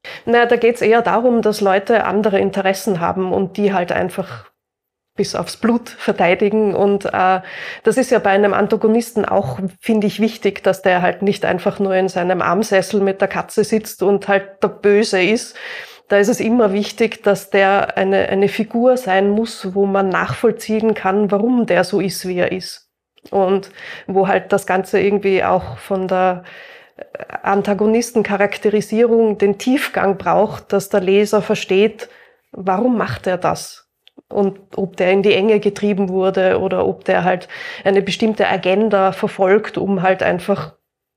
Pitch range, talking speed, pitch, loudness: 190-215 Hz, 165 wpm, 200 Hz, -16 LUFS